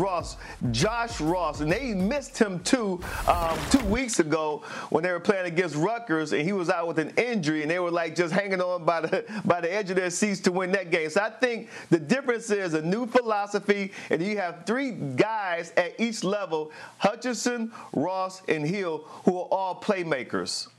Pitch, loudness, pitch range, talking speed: 195 Hz, -27 LUFS, 175-220 Hz, 200 wpm